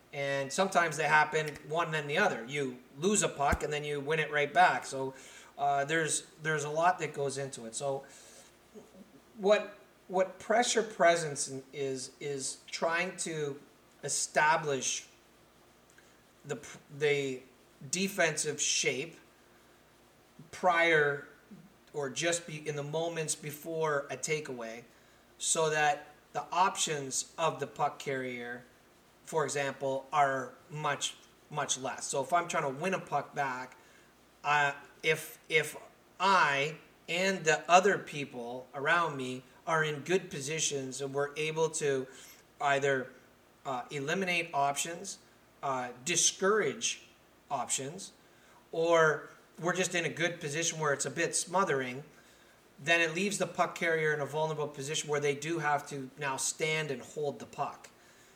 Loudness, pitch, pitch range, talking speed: -32 LUFS, 150 Hz, 140-165 Hz, 140 wpm